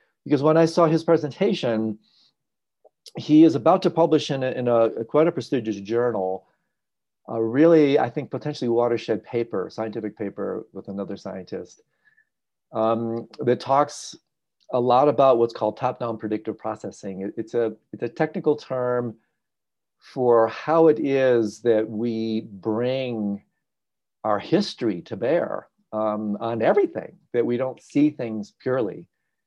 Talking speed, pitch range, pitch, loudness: 145 wpm, 110-150 Hz, 120 Hz, -23 LUFS